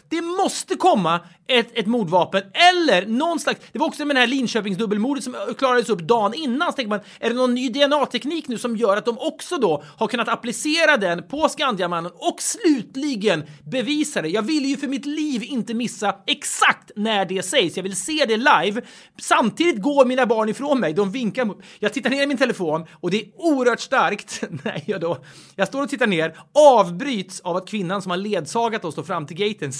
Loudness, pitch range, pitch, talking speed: -21 LUFS, 200-275 Hz, 235 Hz, 205 wpm